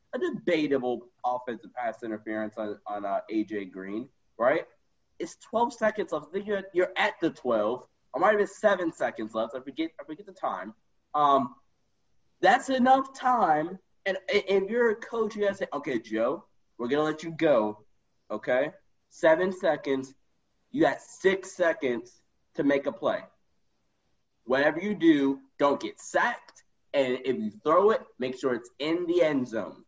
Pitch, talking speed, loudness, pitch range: 160 Hz, 170 wpm, -28 LUFS, 125-195 Hz